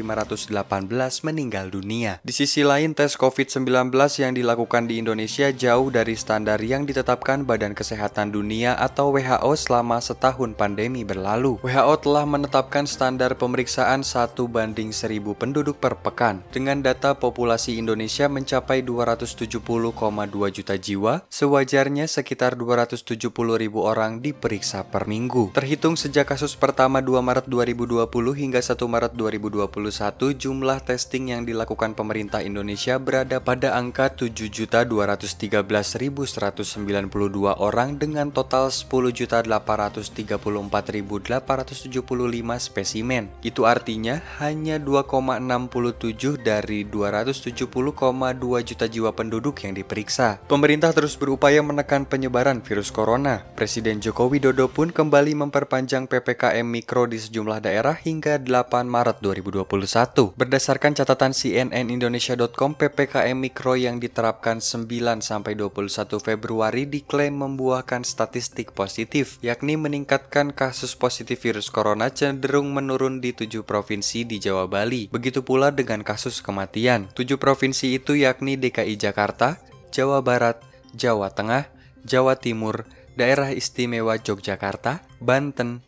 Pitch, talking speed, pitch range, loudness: 125 Hz, 110 wpm, 110-135 Hz, -23 LUFS